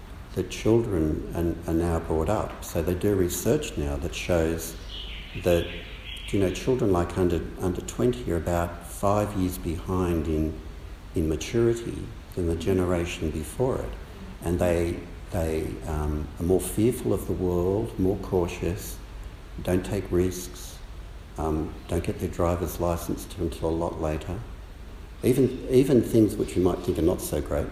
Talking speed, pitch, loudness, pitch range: 155 wpm, 90 Hz, -27 LUFS, 80-95 Hz